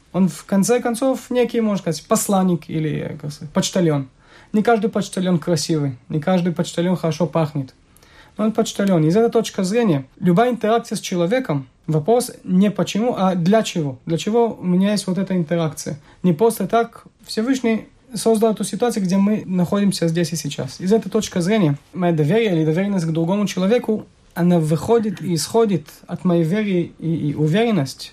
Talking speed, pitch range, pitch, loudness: 165 wpm, 165-220 Hz, 185 Hz, -19 LUFS